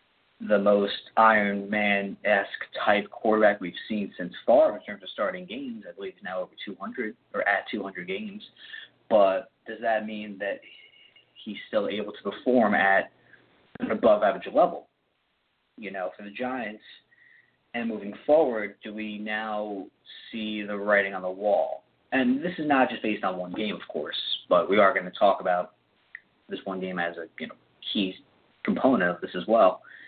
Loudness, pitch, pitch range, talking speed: -26 LUFS, 105 Hz, 100-125 Hz, 180 wpm